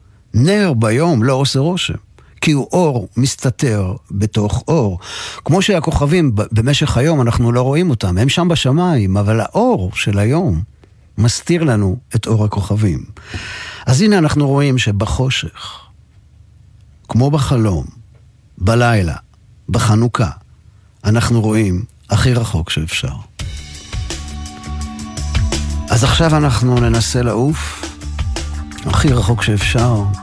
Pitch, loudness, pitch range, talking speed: 115 Hz, -15 LUFS, 100-130 Hz, 105 wpm